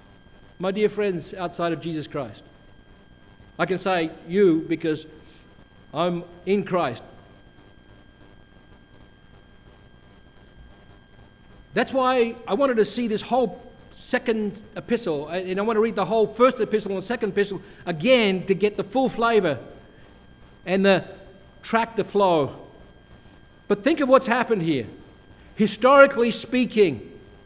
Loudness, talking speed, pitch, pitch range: -22 LUFS, 120 wpm, 200 Hz, 175-230 Hz